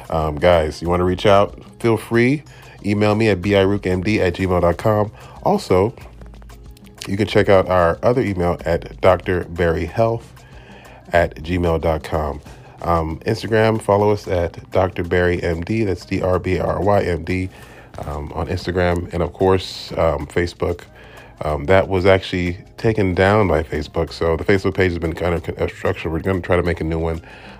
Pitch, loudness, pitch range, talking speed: 90 Hz, -19 LUFS, 85-105 Hz, 160 wpm